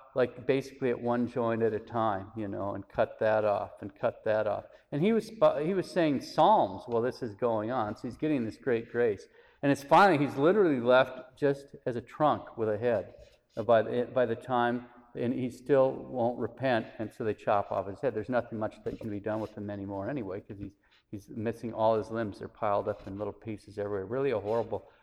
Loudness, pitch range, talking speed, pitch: -30 LUFS, 110-135 Hz, 225 wpm, 120 Hz